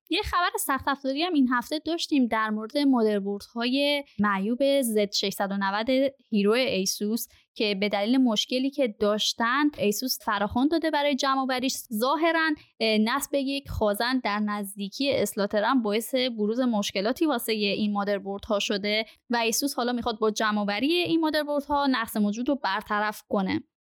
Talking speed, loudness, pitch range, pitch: 145 wpm, -26 LUFS, 210-275 Hz, 235 Hz